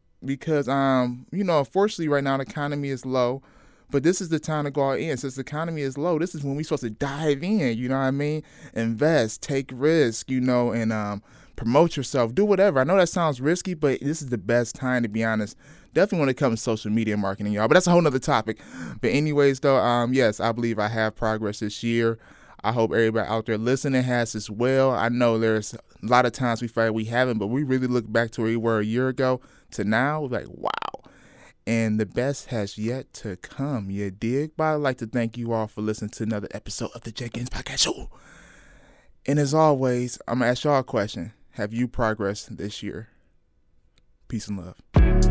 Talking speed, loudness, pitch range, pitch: 225 wpm, -24 LUFS, 110-140 Hz, 125 Hz